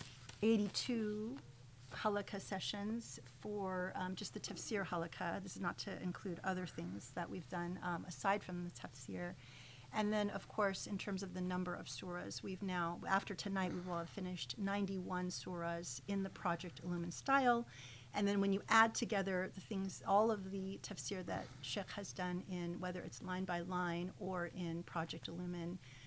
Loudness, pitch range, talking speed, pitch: -41 LUFS, 170-200 Hz, 175 wpm, 185 Hz